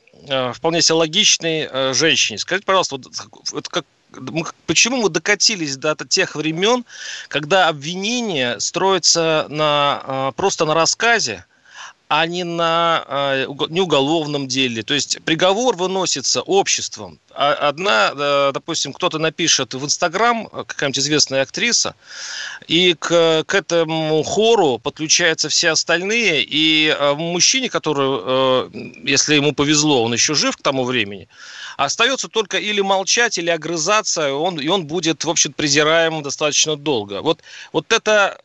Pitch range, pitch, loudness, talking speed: 145-190 Hz, 160 Hz, -17 LUFS, 135 wpm